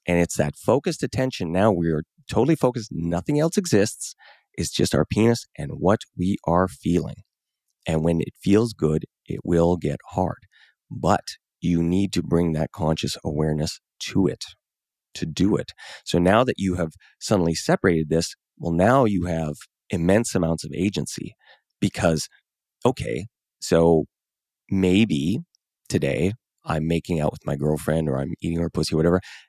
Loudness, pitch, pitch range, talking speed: -23 LUFS, 85 Hz, 80-100 Hz, 160 wpm